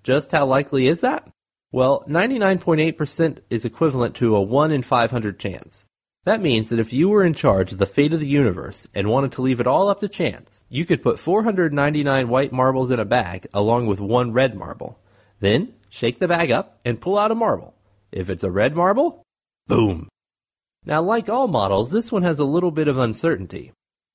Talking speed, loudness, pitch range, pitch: 200 wpm, -20 LUFS, 115-170 Hz, 135 Hz